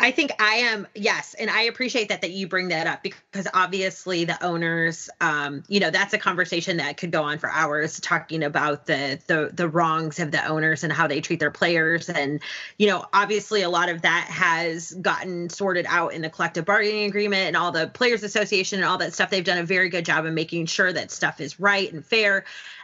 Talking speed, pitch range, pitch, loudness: 225 wpm, 160-200 Hz, 175 Hz, -23 LUFS